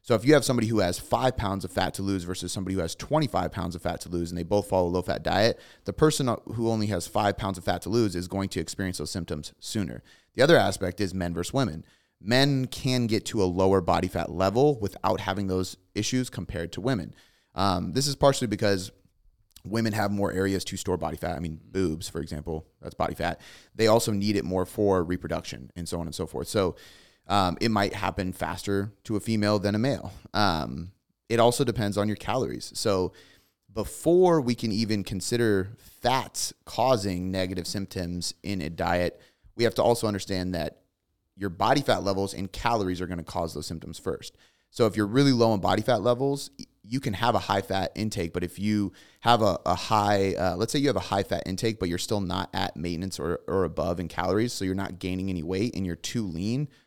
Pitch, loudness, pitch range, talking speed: 95 Hz, -27 LUFS, 90-110 Hz, 220 wpm